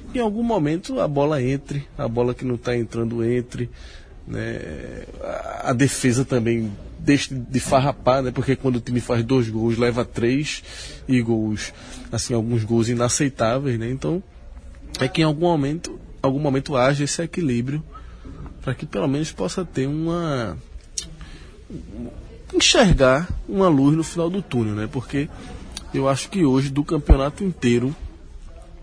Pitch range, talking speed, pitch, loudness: 115-145 Hz, 150 wpm, 130 Hz, -22 LUFS